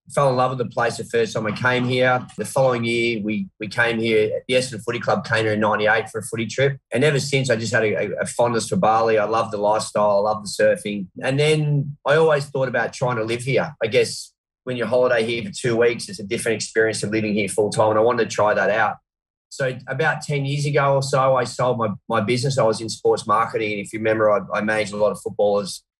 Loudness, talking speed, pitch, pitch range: -20 LUFS, 265 wpm, 115 Hz, 110-130 Hz